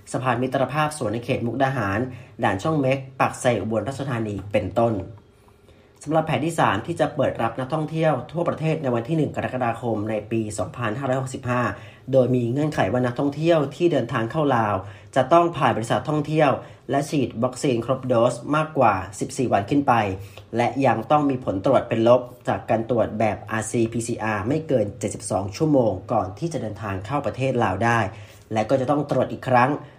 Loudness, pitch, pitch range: -23 LUFS, 125 Hz, 110-140 Hz